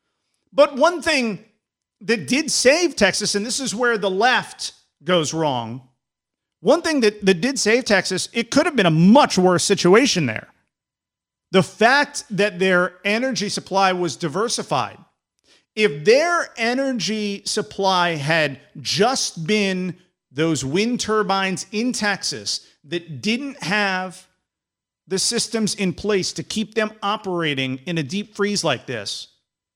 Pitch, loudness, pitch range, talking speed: 200 Hz, -20 LUFS, 175-225 Hz, 135 wpm